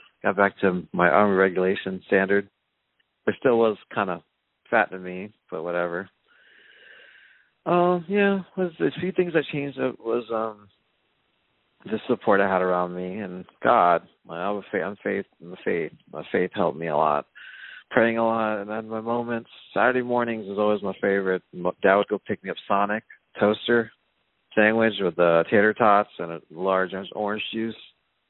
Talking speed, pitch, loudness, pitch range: 170 wpm, 105 Hz, -24 LUFS, 95-115 Hz